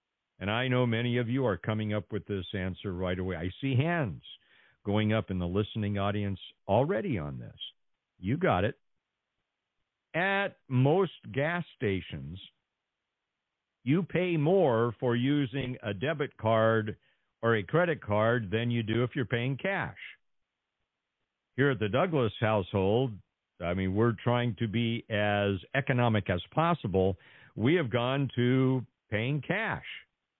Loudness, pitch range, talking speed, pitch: -30 LUFS, 100-135 Hz, 145 wpm, 115 Hz